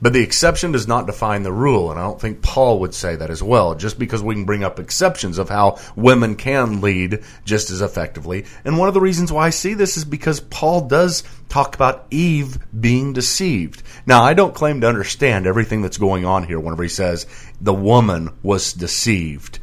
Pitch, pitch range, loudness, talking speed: 115 Hz, 95-140 Hz, -17 LUFS, 210 wpm